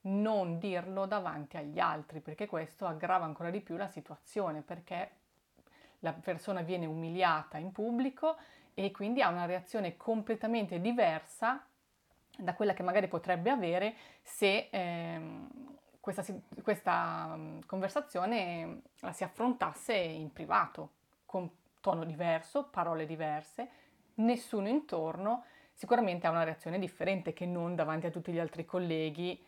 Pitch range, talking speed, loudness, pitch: 165-215 Hz, 130 wpm, -35 LUFS, 180 Hz